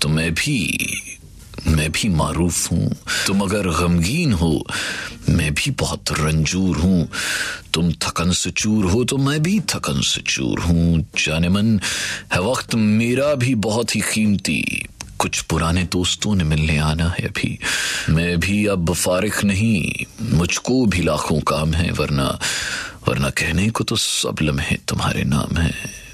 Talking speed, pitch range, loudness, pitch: 150 wpm, 80-105 Hz, -19 LUFS, 90 Hz